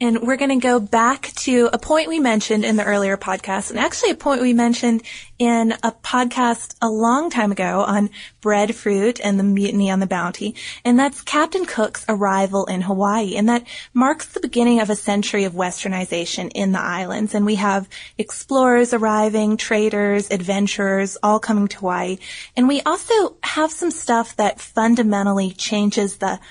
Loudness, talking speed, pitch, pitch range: -19 LUFS, 175 wpm, 215 Hz, 200-245 Hz